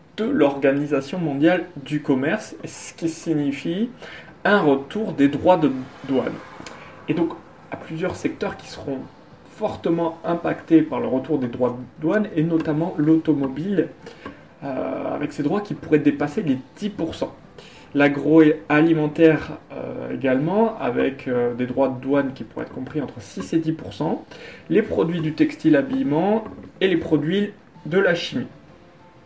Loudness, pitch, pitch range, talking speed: -22 LUFS, 155 Hz, 140-170 Hz, 145 wpm